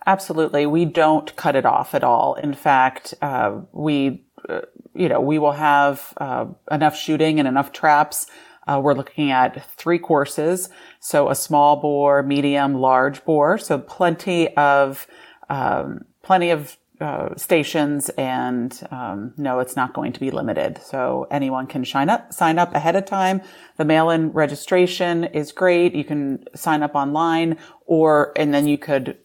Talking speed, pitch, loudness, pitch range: 160 wpm, 150 Hz, -19 LUFS, 140-165 Hz